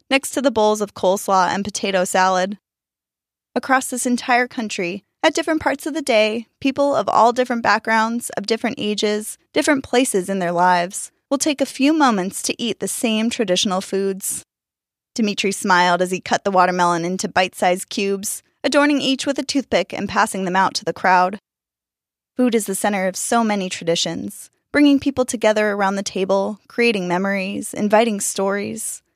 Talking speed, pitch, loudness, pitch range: 170 wpm, 210 Hz, -19 LUFS, 190-250 Hz